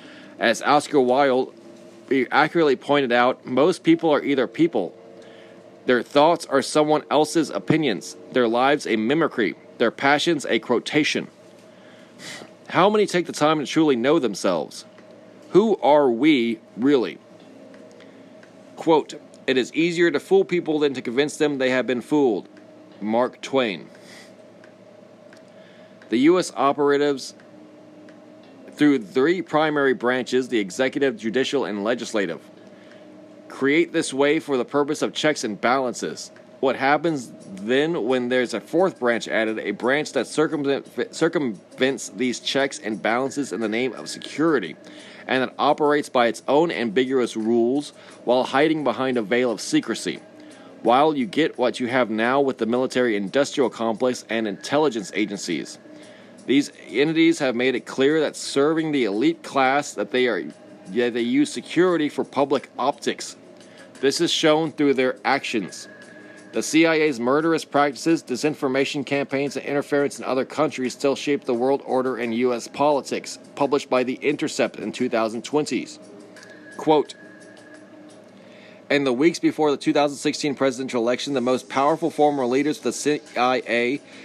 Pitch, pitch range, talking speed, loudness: 140 Hz, 125-155 Hz, 140 wpm, -22 LUFS